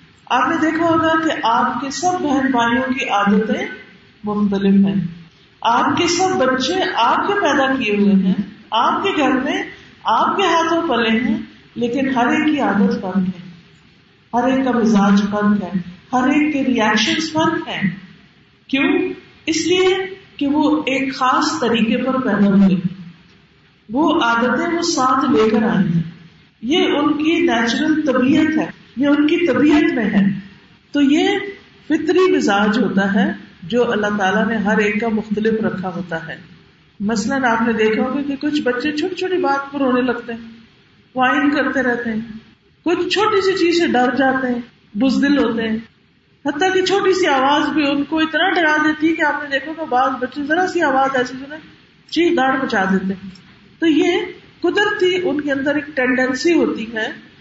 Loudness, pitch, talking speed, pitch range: -17 LUFS, 260 Hz, 175 wpm, 220-315 Hz